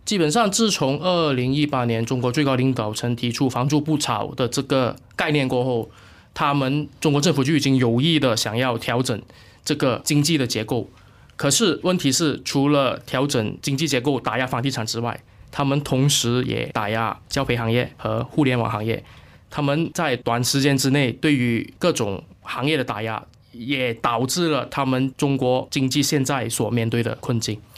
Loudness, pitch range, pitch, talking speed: -21 LUFS, 120-145 Hz, 130 Hz, 270 characters per minute